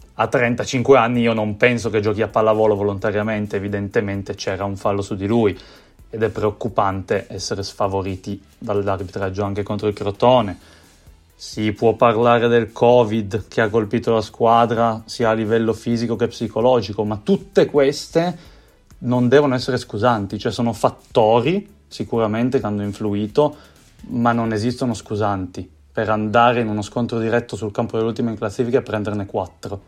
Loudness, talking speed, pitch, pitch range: -19 LUFS, 155 wpm, 110 Hz, 105-120 Hz